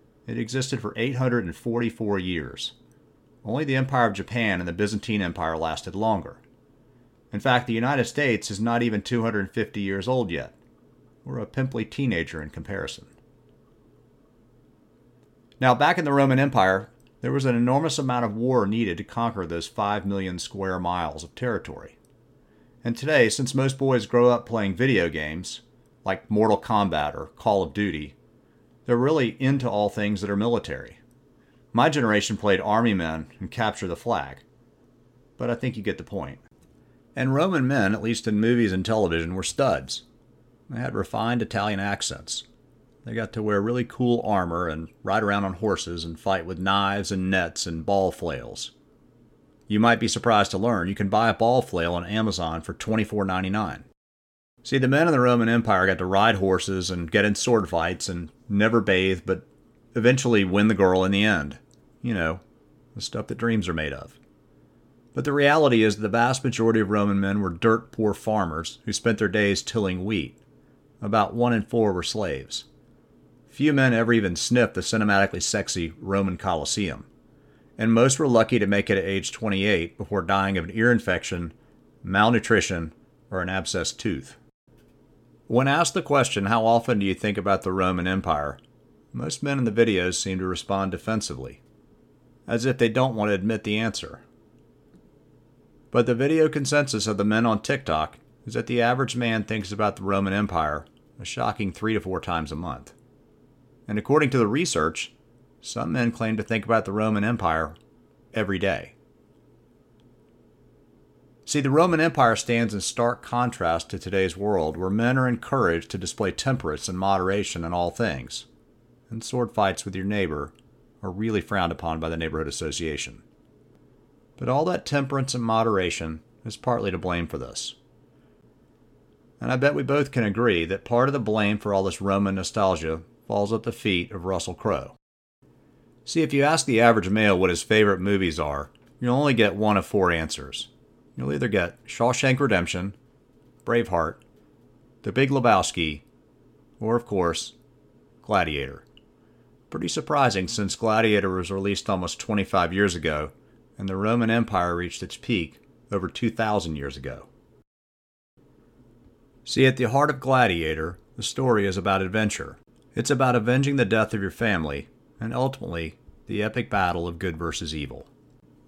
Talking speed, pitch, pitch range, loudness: 170 wpm, 105 Hz, 95-120 Hz, -24 LUFS